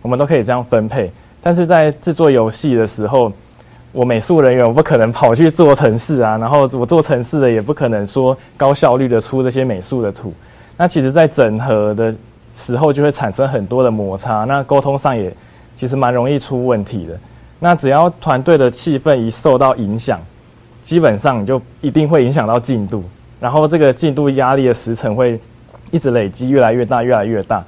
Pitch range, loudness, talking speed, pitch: 115-145 Hz, -14 LUFS, 300 characters per minute, 125 Hz